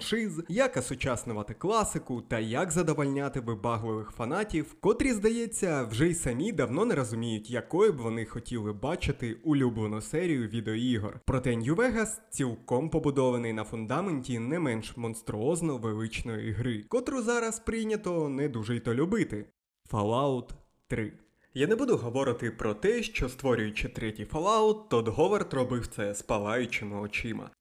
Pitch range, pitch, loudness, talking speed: 115-160 Hz, 125 Hz, -30 LUFS, 135 wpm